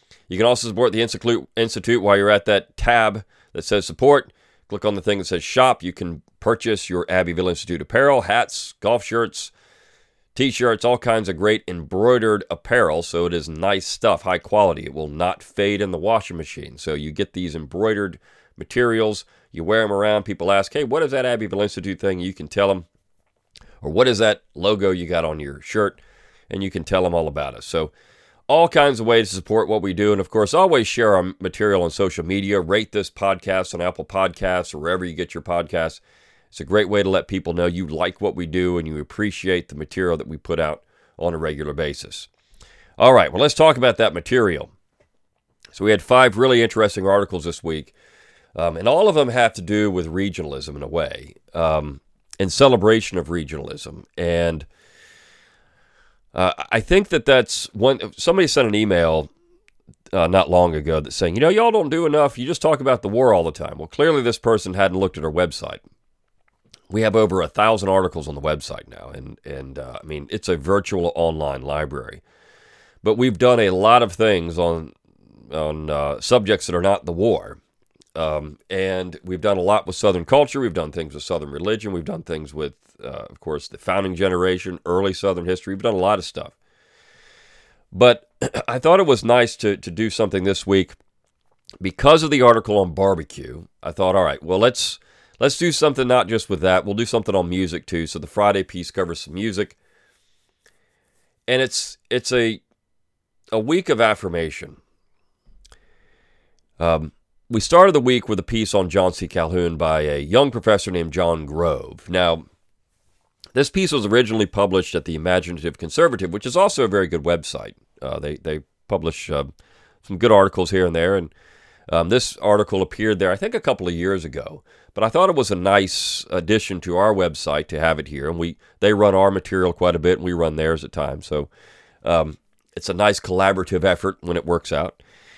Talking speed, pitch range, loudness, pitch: 200 wpm, 85-110 Hz, -19 LUFS, 95 Hz